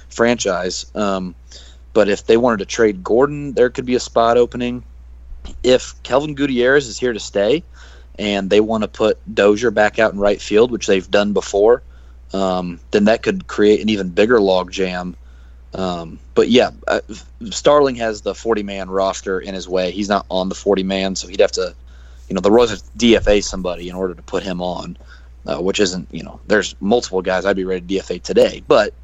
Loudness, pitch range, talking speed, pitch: -17 LUFS, 85-110 Hz, 200 wpm, 95 Hz